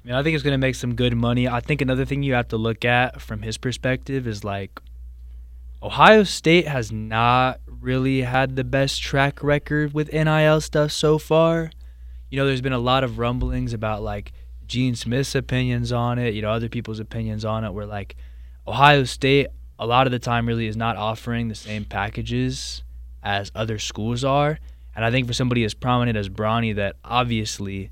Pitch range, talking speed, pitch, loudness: 105-130 Hz, 200 wpm, 120 Hz, -22 LUFS